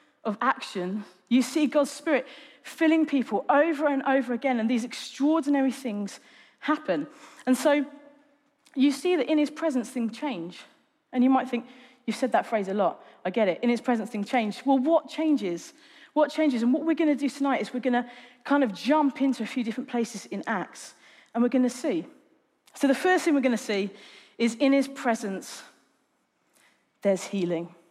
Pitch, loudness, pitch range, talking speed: 265 Hz, -26 LUFS, 235-295 Hz, 195 wpm